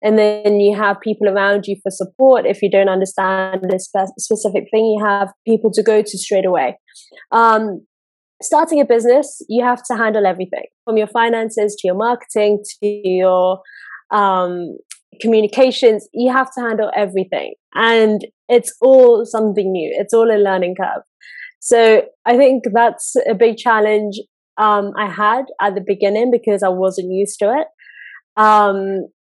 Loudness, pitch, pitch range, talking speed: -15 LUFS, 215 Hz, 200-235 Hz, 160 wpm